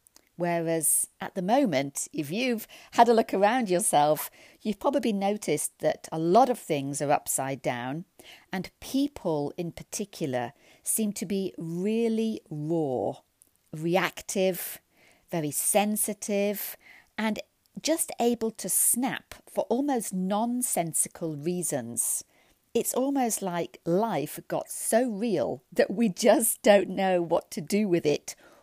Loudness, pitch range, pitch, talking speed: -27 LUFS, 160-225 Hz, 190 Hz, 125 wpm